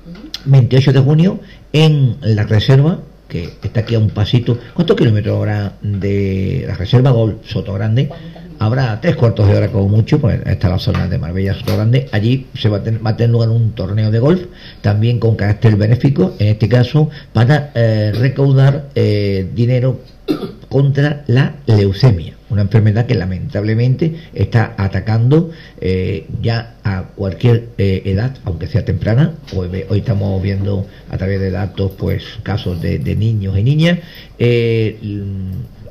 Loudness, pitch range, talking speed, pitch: -15 LUFS, 100-130 Hz, 160 wpm, 115 Hz